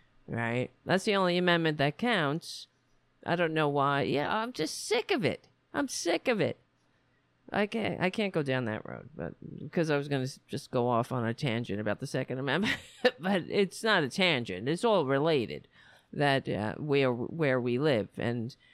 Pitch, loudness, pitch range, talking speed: 145 Hz, -30 LUFS, 130-180 Hz, 190 wpm